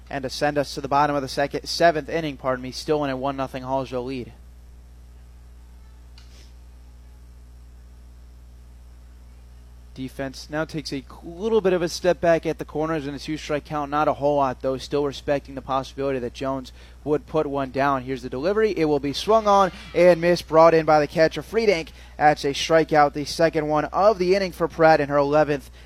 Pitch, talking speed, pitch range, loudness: 140 Hz, 190 wpm, 120-155 Hz, -22 LUFS